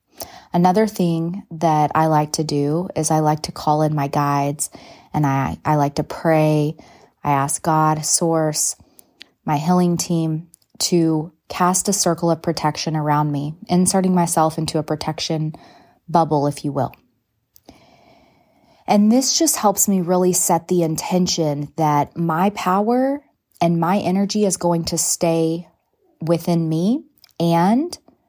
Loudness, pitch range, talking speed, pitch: -19 LUFS, 155-180 Hz, 140 wpm, 165 Hz